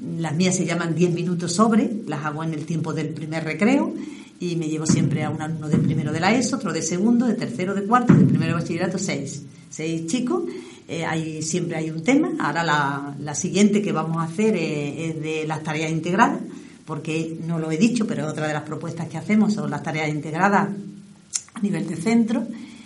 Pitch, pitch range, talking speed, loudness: 170 Hz, 155-210 Hz, 215 wpm, -22 LUFS